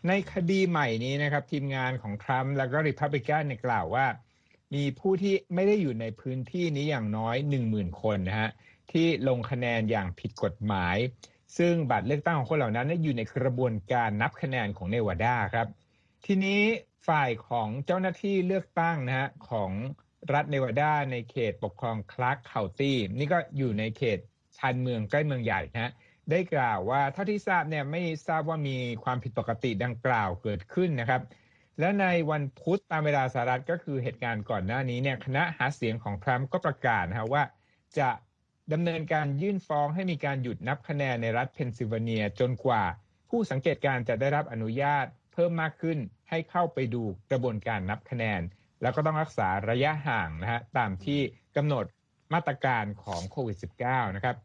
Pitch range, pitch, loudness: 115-155 Hz, 130 Hz, -29 LUFS